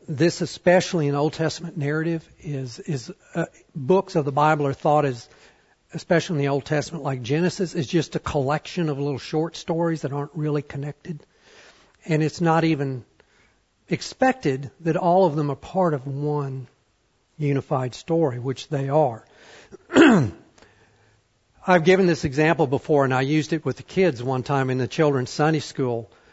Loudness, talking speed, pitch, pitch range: -23 LUFS, 165 wpm, 150 Hz, 140-165 Hz